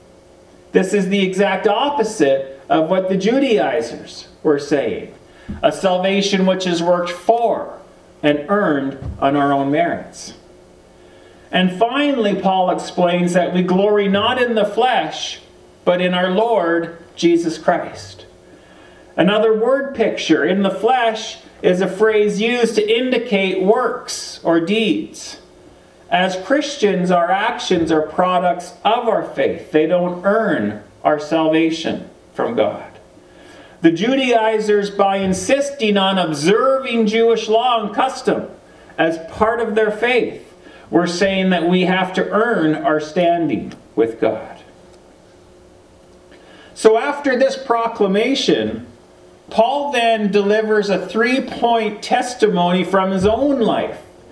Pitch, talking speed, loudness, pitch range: 195 Hz, 125 wpm, -17 LUFS, 175-225 Hz